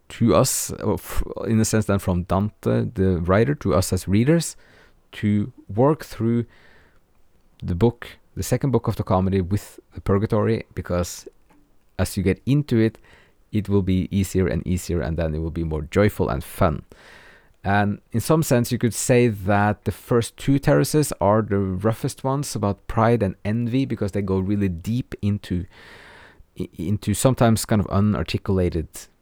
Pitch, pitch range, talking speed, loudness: 105 Hz, 95-115 Hz, 165 wpm, -22 LUFS